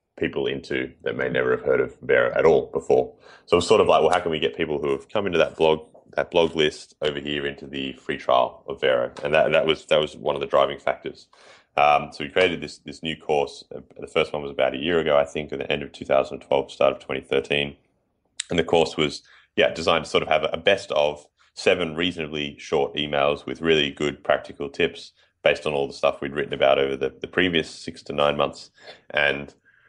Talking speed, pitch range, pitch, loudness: 235 wpm, 70-85 Hz, 75 Hz, -23 LUFS